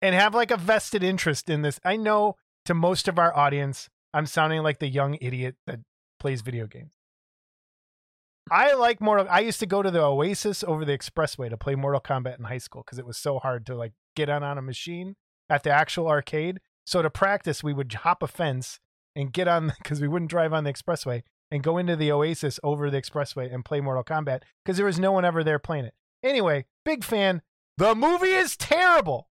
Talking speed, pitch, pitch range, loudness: 220 wpm, 155 Hz, 140-185 Hz, -25 LUFS